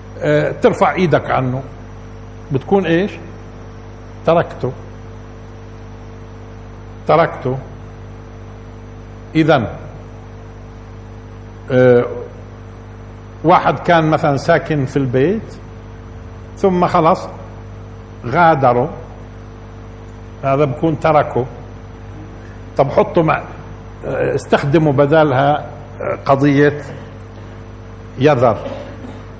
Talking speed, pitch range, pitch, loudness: 55 wpm, 110-135 Hz, 110 Hz, -15 LUFS